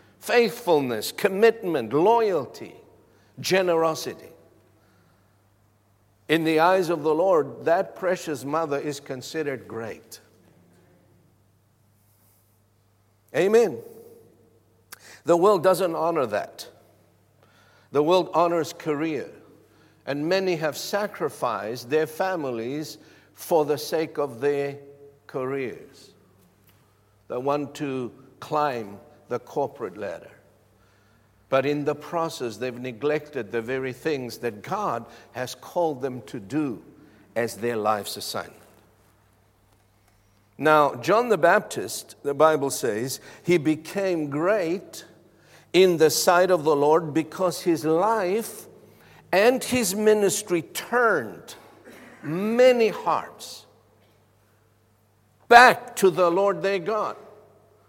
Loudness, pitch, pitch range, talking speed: -23 LUFS, 140 Hz, 105-165 Hz, 100 wpm